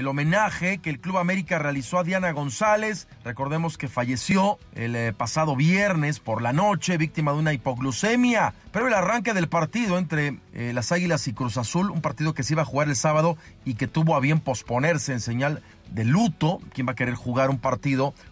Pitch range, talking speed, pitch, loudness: 130-175 Hz, 200 wpm, 150 Hz, -24 LUFS